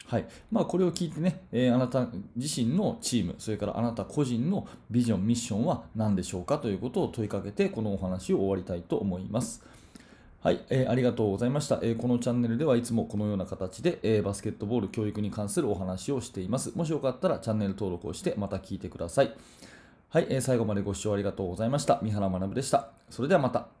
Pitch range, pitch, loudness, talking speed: 100-125 Hz, 115 Hz, -29 LUFS, 495 characters per minute